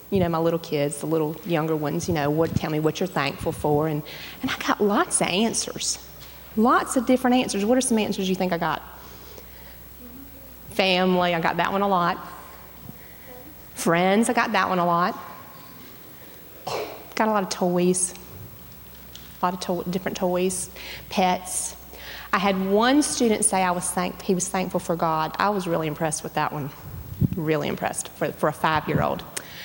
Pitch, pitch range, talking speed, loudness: 180 Hz, 160-200 Hz, 180 wpm, -23 LUFS